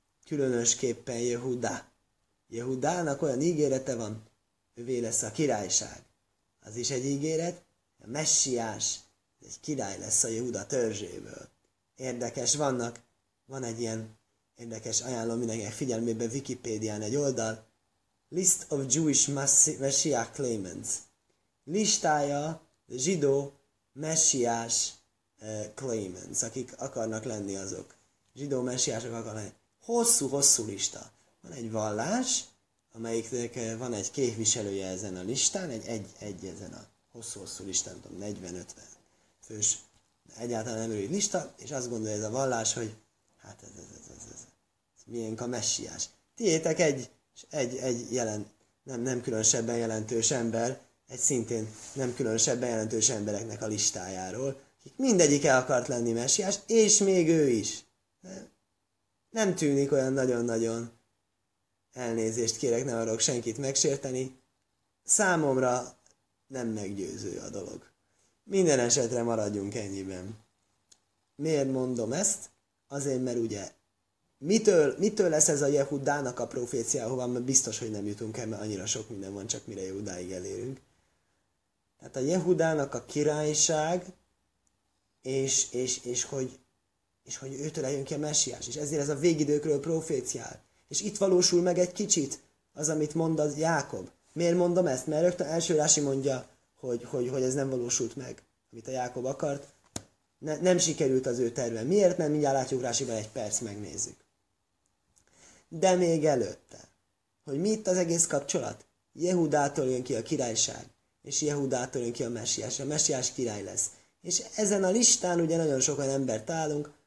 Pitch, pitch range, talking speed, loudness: 125 Hz, 110-145 Hz, 140 wpm, -29 LUFS